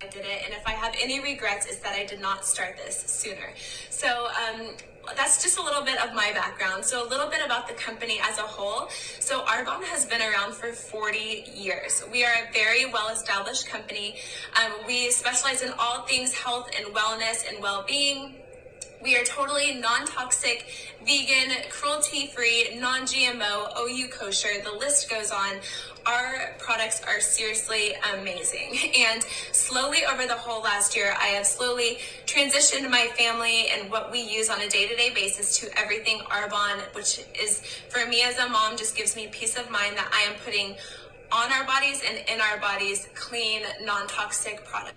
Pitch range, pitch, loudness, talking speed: 210-275 Hz, 235 Hz, -25 LUFS, 175 wpm